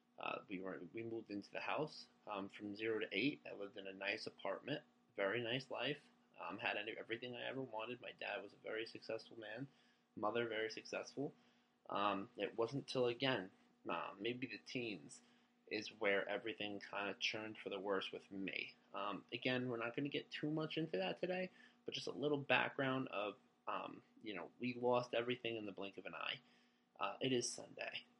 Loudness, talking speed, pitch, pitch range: -44 LUFS, 195 wpm, 120 Hz, 105-130 Hz